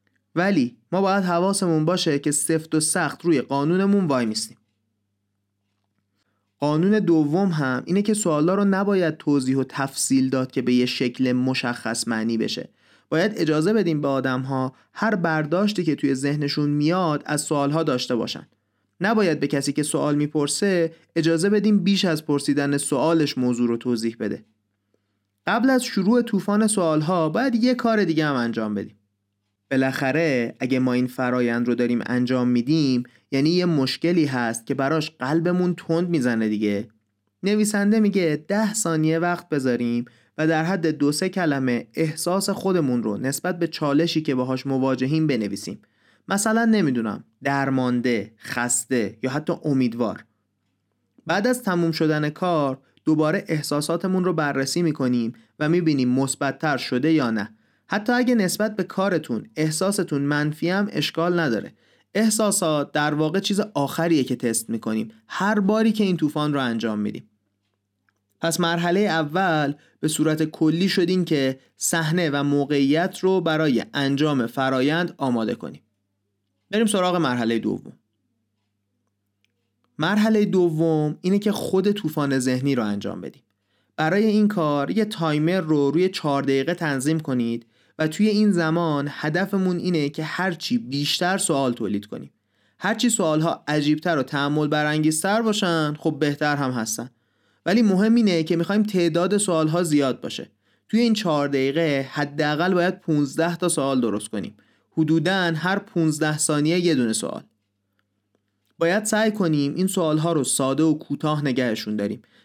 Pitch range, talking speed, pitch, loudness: 125-175 Hz, 145 wpm, 150 Hz, -22 LUFS